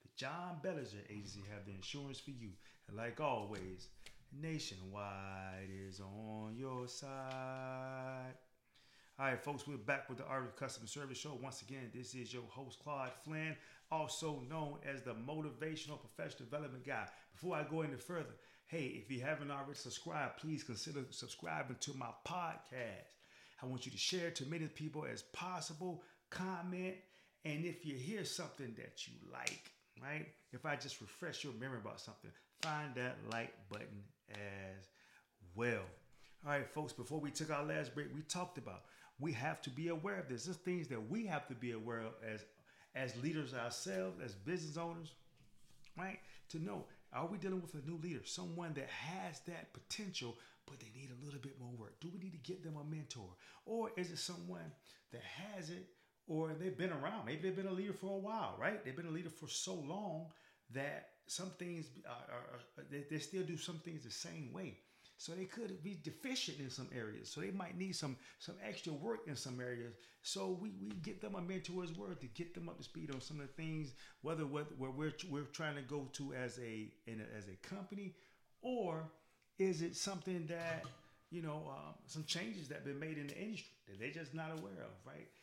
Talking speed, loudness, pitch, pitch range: 195 wpm, -46 LUFS, 145 Hz, 125-170 Hz